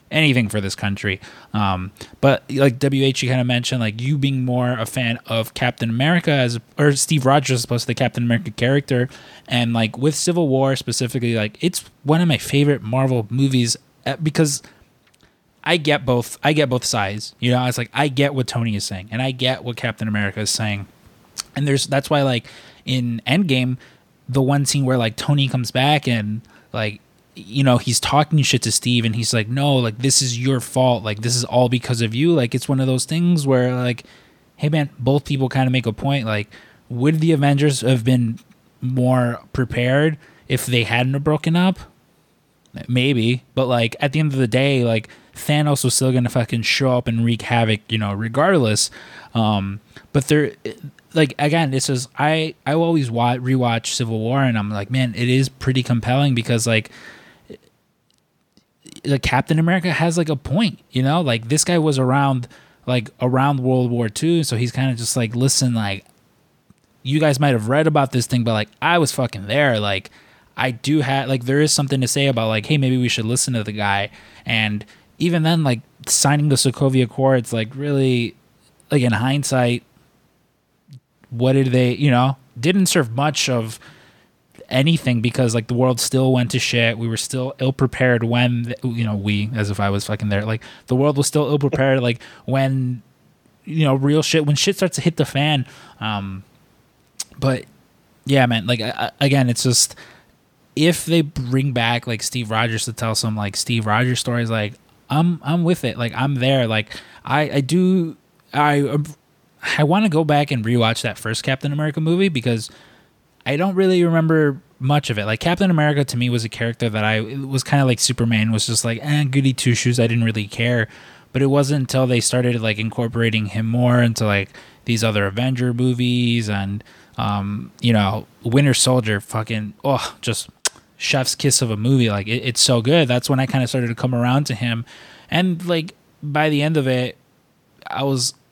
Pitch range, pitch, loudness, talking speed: 115-140 Hz, 130 Hz, -19 LUFS, 200 wpm